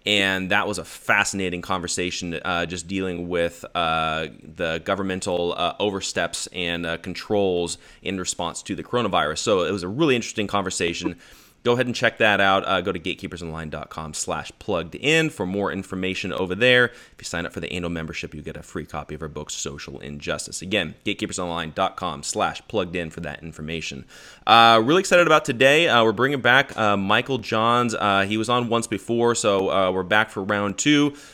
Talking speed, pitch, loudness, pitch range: 190 wpm, 95 Hz, -22 LUFS, 85-110 Hz